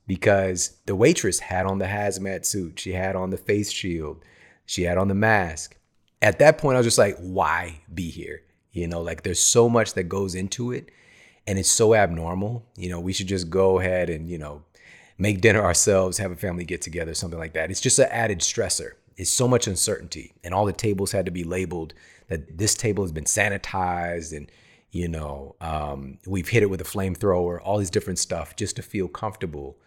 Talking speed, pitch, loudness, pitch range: 210 wpm, 95 Hz, -23 LUFS, 85-100 Hz